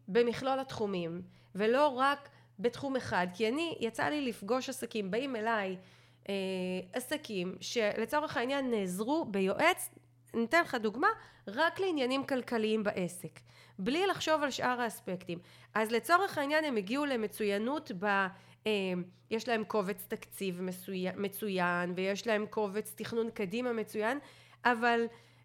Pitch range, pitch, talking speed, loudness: 195-260 Hz, 220 Hz, 125 wpm, -33 LUFS